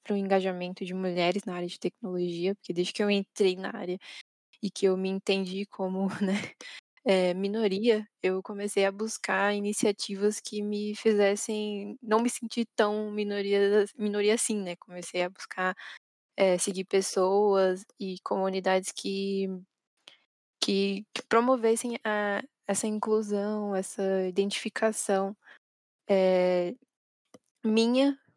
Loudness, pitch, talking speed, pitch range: -29 LUFS, 200 Hz, 125 wpm, 190-215 Hz